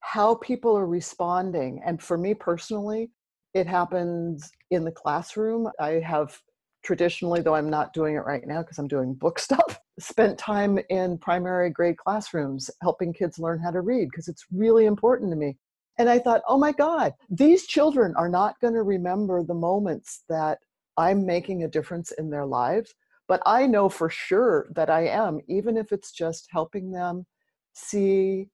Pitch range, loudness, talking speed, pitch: 165-215 Hz, -25 LUFS, 175 wpm, 180 Hz